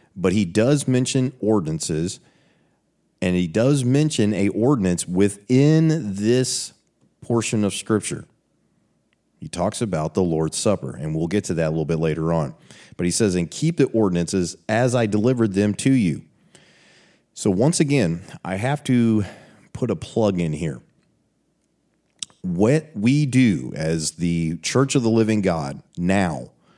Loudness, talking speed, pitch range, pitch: -21 LUFS, 150 wpm, 90-130 Hz, 105 Hz